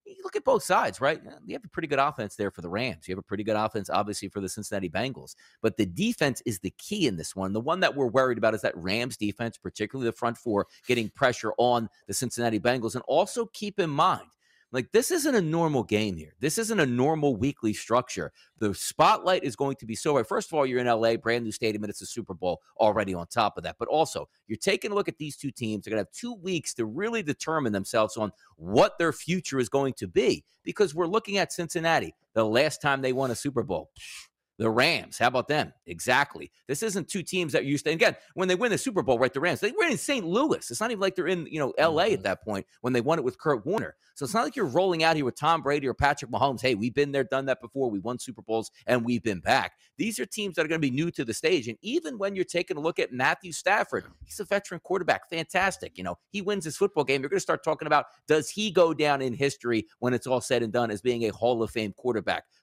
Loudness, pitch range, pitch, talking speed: -27 LUFS, 115-175 Hz, 135 Hz, 265 wpm